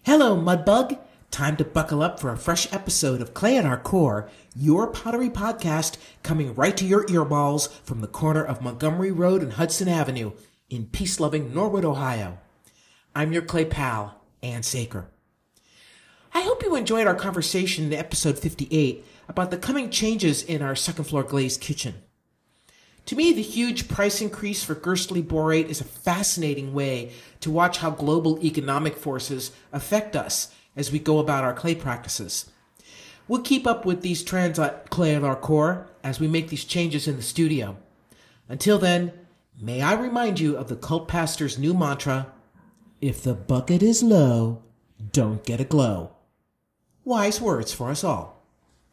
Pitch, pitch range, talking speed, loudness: 155 Hz, 135-180 Hz, 165 wpm, -24 LUFS